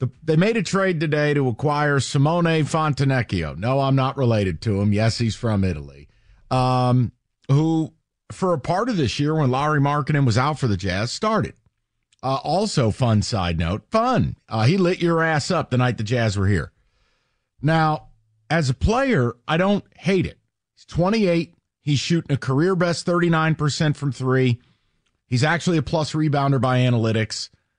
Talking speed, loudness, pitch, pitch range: 170 wpm, -21 LUFS, 135 Hz, 115-160 Hz